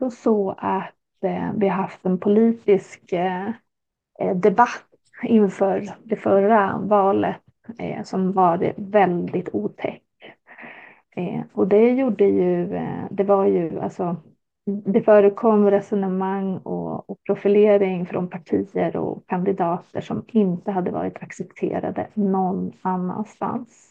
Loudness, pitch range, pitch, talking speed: -21 LUFS, 185-210 Hz, 195 Hz, 115 wpm